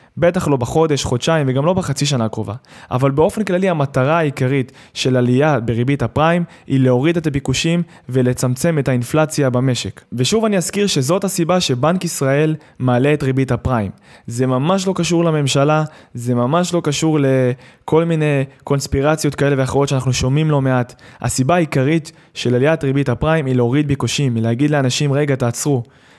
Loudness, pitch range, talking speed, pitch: -17 LUFS, 130-160 Hz, 155 wpm, 140 Hz